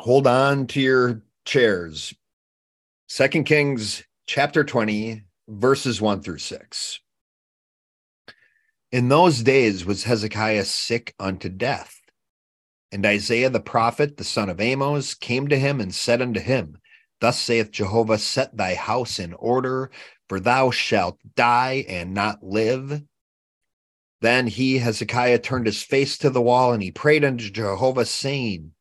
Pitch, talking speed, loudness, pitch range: 120 Hz, 135 wpm, -21 LUFS, 105-130 Hz